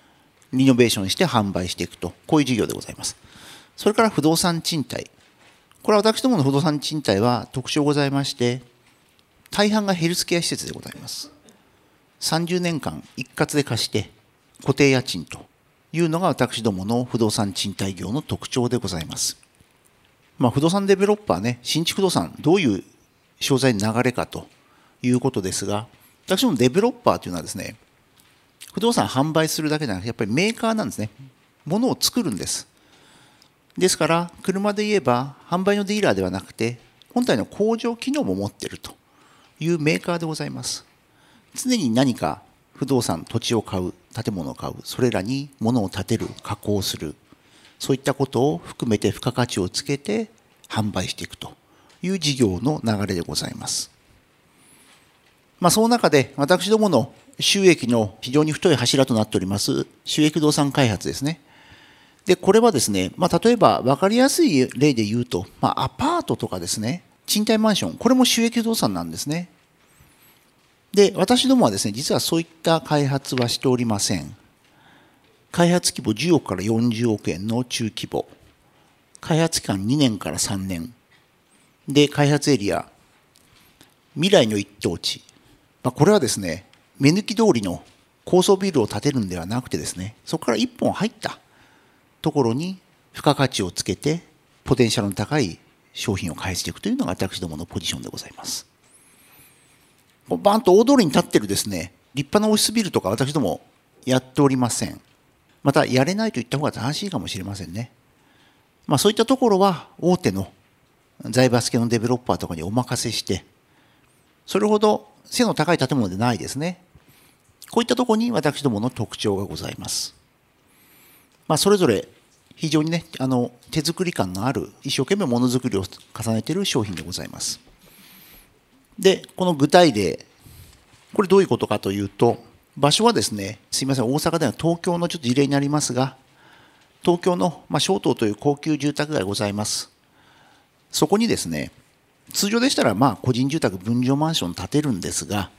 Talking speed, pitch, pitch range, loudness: 340 characters per minute, 135 Hz, 110-175 Hz, -21 LUFS